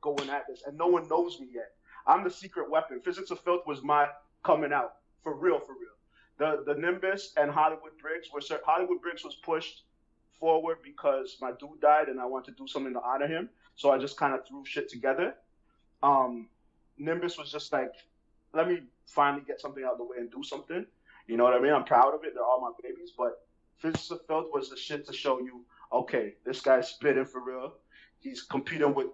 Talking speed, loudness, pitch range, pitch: 220 wpm, -30 LUFS, 140-180 Hz, 155 Hz